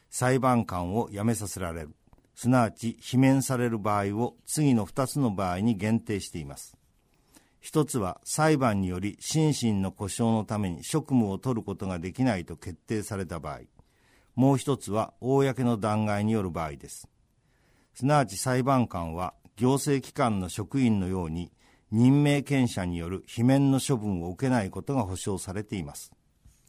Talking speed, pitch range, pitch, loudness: 310 characters per minute, 95-130 Hz, 115 Hz, -27 LUFS